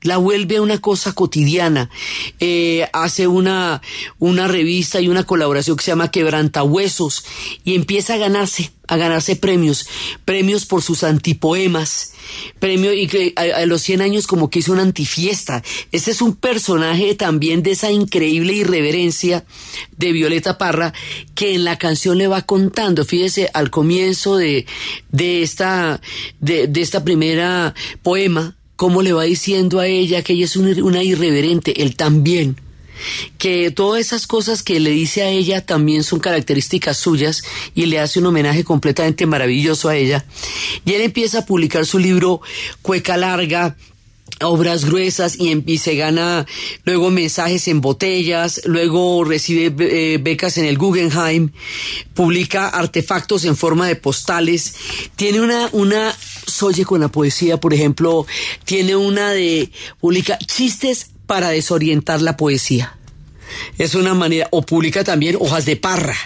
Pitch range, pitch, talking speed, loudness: 160-185 Hz, 170 Hz, 150 wpm, -16 LUFS